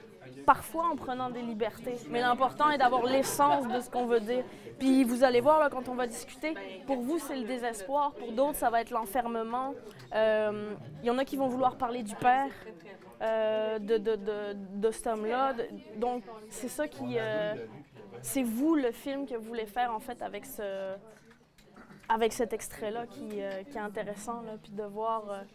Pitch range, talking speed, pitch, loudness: 220-260 Hz, 195 wpm, 240 Hz, -31 LUFS